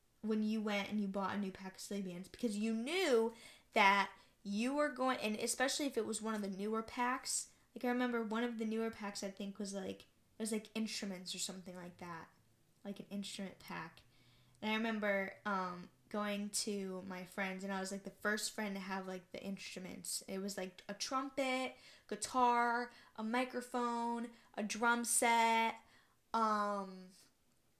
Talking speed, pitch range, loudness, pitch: 180 wpm, 195-235 Hz, -39 LUFS, 210 Hz